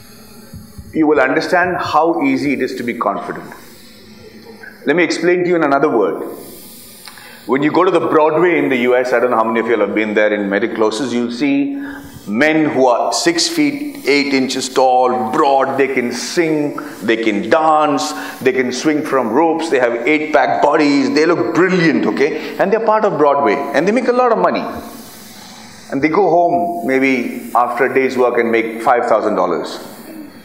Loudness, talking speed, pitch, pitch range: -14 LUFS, 195 wpm, 150 Hz, 125-180 Hz